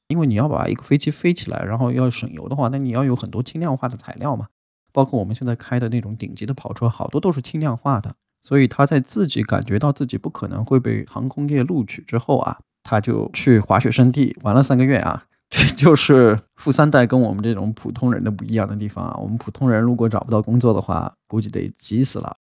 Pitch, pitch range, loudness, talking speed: 125 Hz, 110-135 Hz, -19 LUFS, 360 characters per minute